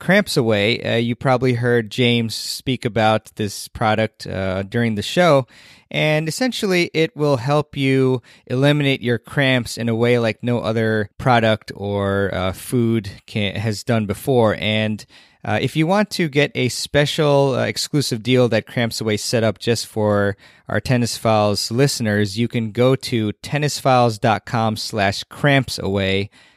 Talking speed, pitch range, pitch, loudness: 150 wpm, 110-135 Hz, 120 Hz, -19 LUFS